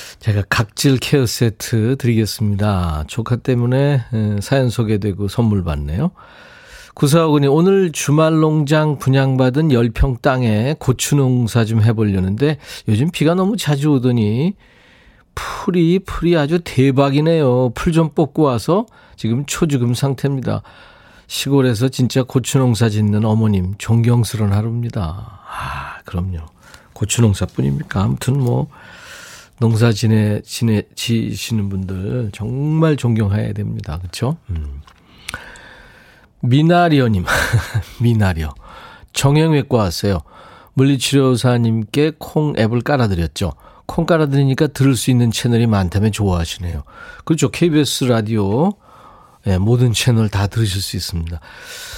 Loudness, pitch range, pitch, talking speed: -17 LUFS, 105-145 Hz, 120 Hz, 280 characters per minute